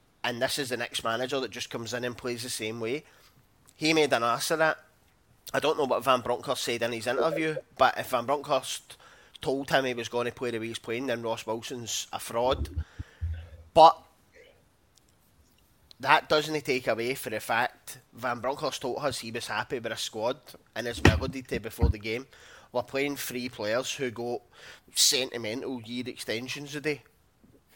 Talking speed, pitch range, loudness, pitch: 185 wpm, 115-130 Hz, -29 LUFS, 120 Hz